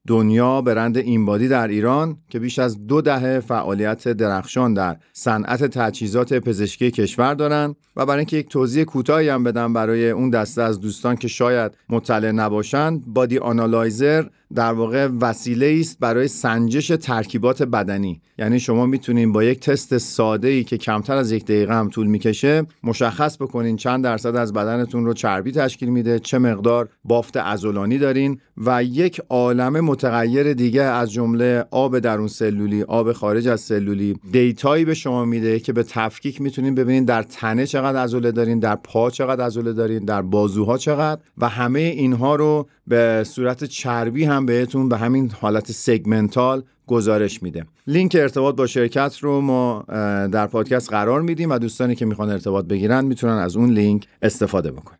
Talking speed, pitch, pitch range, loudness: 165 wpm, 120 Hz, 110-135 Hz, -19 LUFS